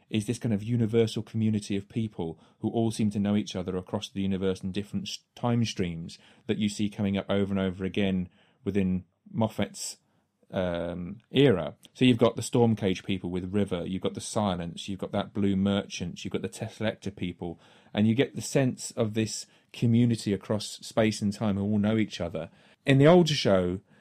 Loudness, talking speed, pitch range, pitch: -28 LUFS, 195 wpm, 95-115 Hz, 105 Hz